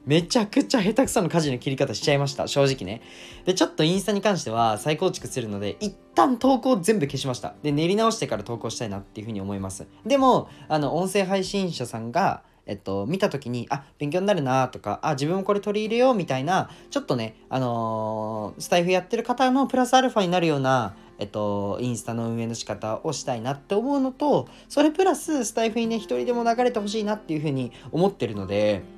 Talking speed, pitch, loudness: 450 characters per minute, 150 Hz, -24 LUFS